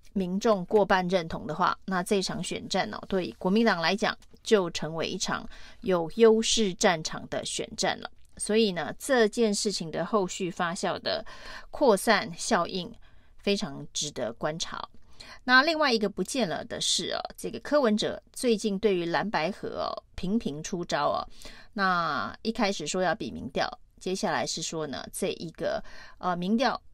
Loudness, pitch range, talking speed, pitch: -28 LUFS, 185-225 Hz, 240 characters per minute, 205 Hz